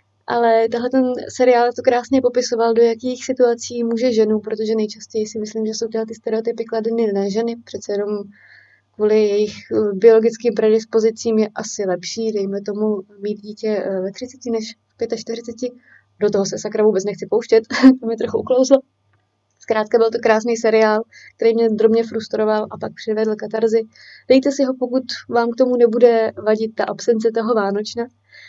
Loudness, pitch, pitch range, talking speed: -18 LUFS, 225 Hz, 215-235 Hz, 165 wpm